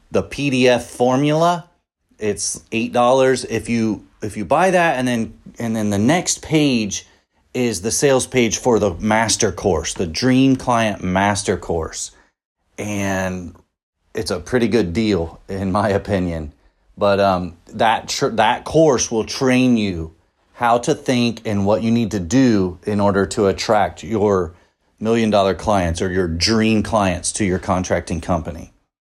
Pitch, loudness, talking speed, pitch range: 105 Hz, -18 LUFS, 155 wpm, 95-120 Hz